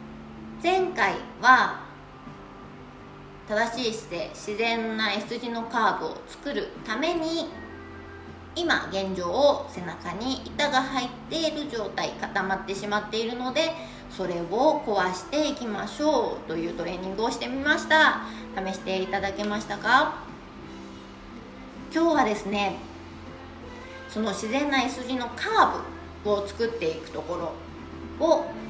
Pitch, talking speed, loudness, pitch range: 225 Hz, 245 characters per minute, -26 LUFS, 195-280 Hz